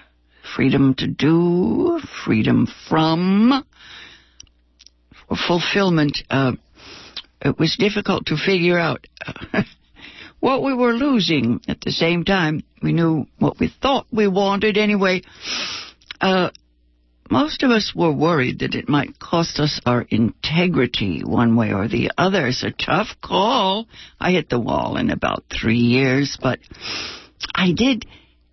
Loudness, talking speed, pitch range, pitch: -19 LUFS, 135 wpm, 120-195 Hz, 160 Hz